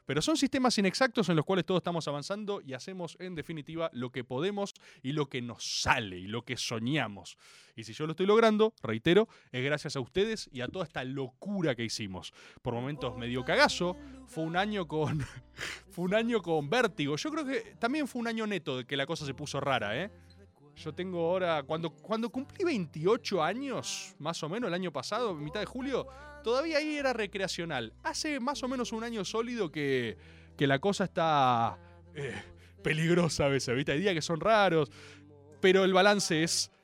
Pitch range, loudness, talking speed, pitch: 135-210 Hz, -31 LUFS, 195 wpm, 165 Hz